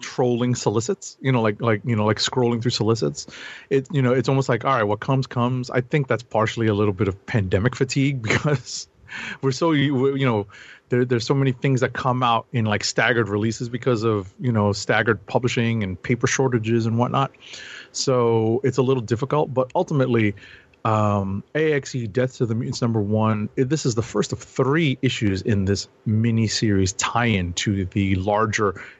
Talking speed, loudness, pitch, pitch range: 190 wpm, -22 LUFS, 120 Hz, 110-130 Hz